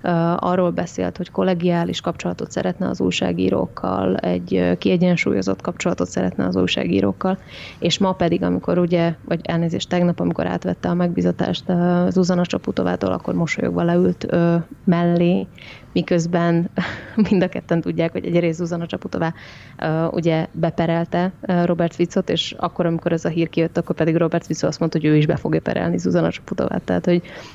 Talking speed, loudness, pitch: 160 wpm, -20 LUFS, 170 Hz